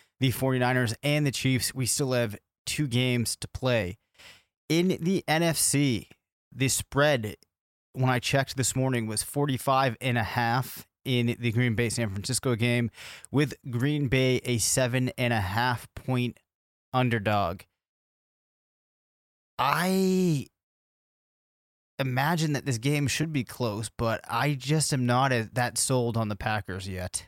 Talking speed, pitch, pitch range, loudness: 140 wpm, 125 Hz, 115-135 Hz, -27 LUFS